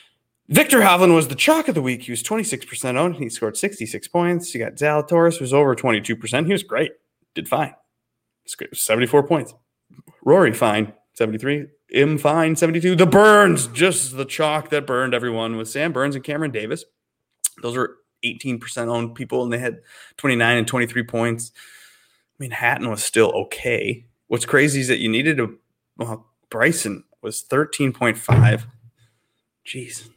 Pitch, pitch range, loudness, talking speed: 130 Hz, 115-155 Hz, -19 LUFS, 160 wpm